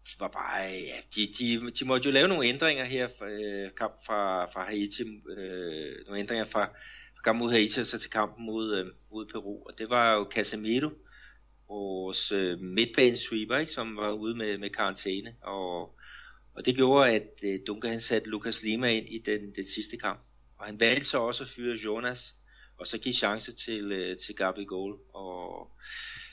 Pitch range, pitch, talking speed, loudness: 100-120 Hz, 110 Hz, 180 wpm, -29 LUFS